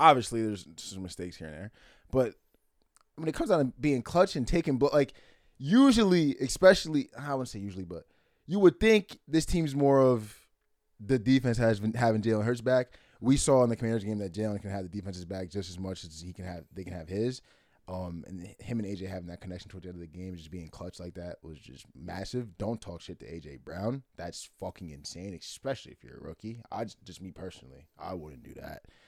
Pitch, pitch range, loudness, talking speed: 105 Hz, 90-130 Hz, -29 LUFS, 230 wpm